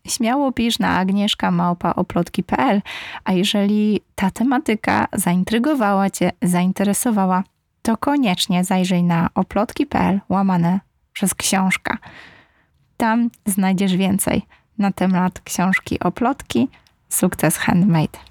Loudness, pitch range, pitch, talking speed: -19 LUFS, 185-220 Hz, 195 Hz, 90 wpm